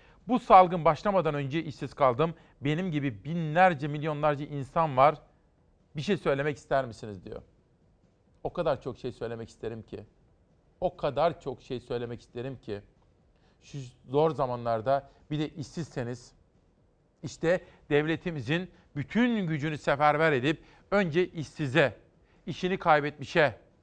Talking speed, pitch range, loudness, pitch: 120 wpm, 130-165 Hz, -28 LUFS, 150 Hz